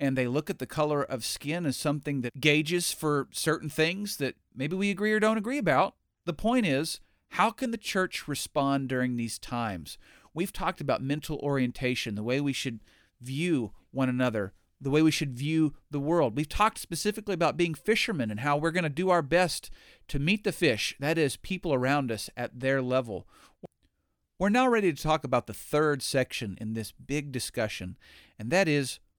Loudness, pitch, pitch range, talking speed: -29 LUFS, 145 Hz, 125-170 Hz, 195 wpm